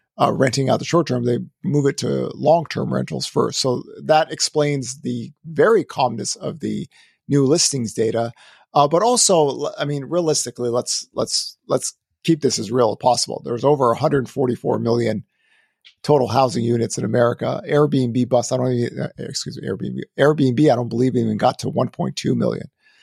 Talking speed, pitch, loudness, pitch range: 175 wpm, 135 Hz, -20 LUFS, 120-150 Hz